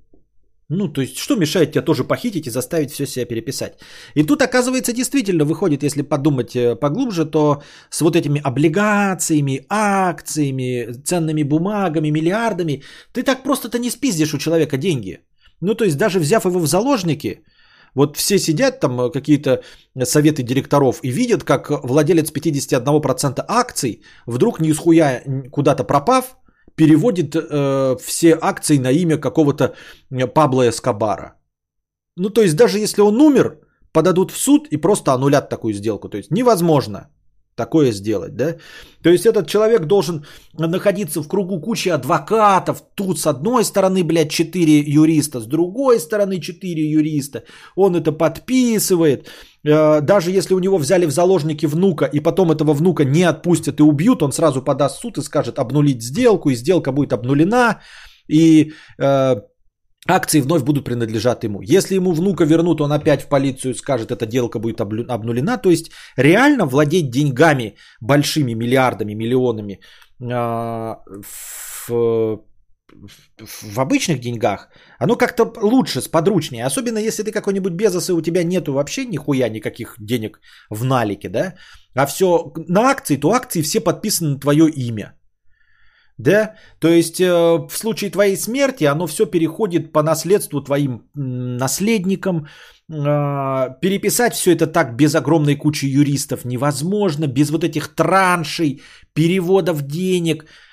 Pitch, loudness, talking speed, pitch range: 155 Hz, -17 LUFS, 145 wpm, 135-185 Hz